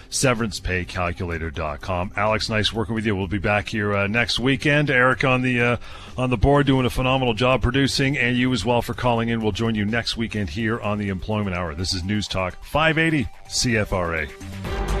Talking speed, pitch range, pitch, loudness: 190 wpm, 95-125 Hz, 110 Hz, -22 LUFS